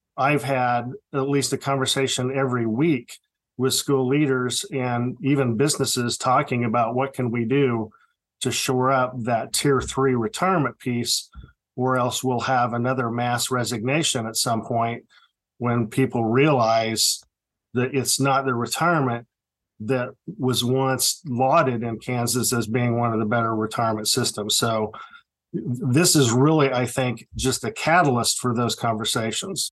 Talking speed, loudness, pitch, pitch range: 145 wpm, -22 LUFS, 125 Hz, 120-135 Hz